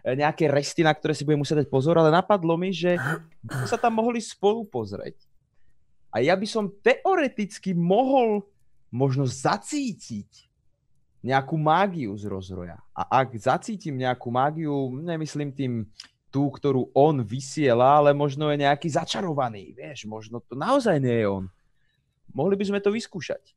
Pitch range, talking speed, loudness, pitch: 130-190 Hz, 145 wpm, -24 LUFS, 150 Hz